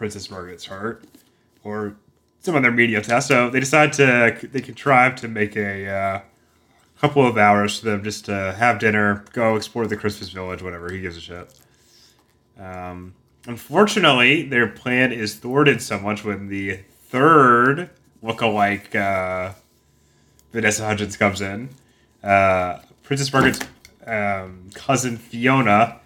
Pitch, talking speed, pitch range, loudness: 105 Hz, 140 wpm, 95-120 Hz, -19 LUFS